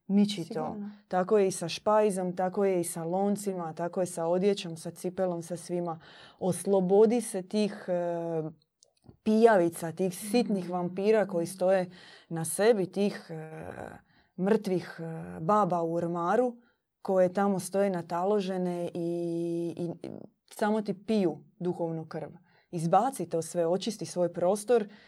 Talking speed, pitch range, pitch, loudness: 125 wpm, 170-200 Hz, 180 Hz, -29 LUFS